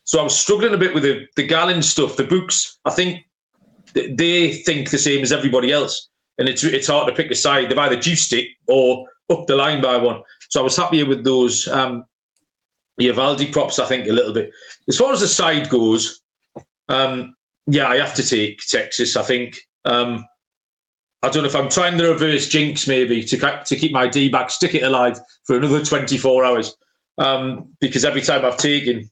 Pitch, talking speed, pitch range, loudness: 135 Hz, 210 wpm, 125-155 Hz, -17 LUFS